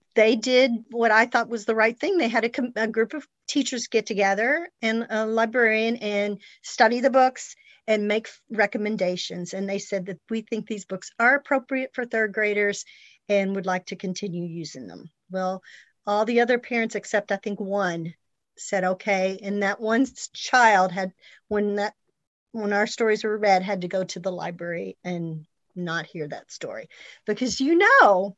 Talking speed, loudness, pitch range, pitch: 185 wpm, -24 LUFS, 190-230 Hz, 210 Hz